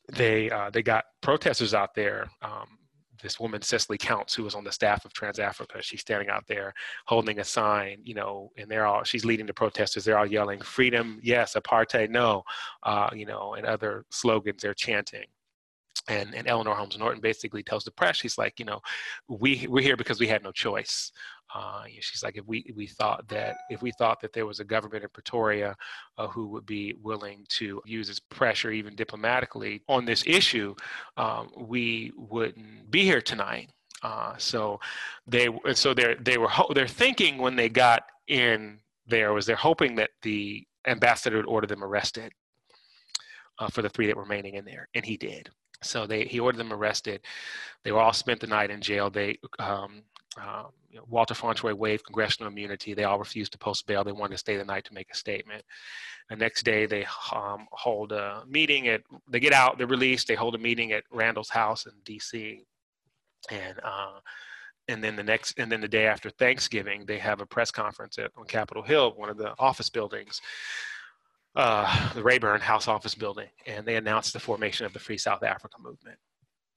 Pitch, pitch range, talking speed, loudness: 110 Hz, 105-115 Hz, 200 wpm, -27 LUFS